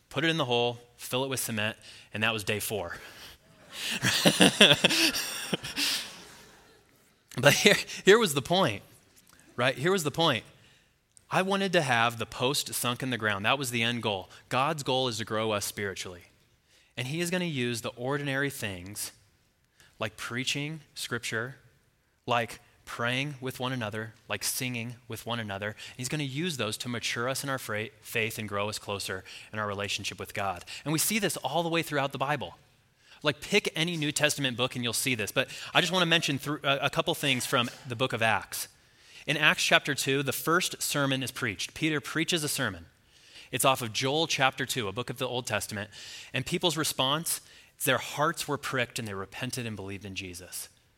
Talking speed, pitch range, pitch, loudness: 190 wpm, 110-145 Hz, 130 Hz, -28 LUFS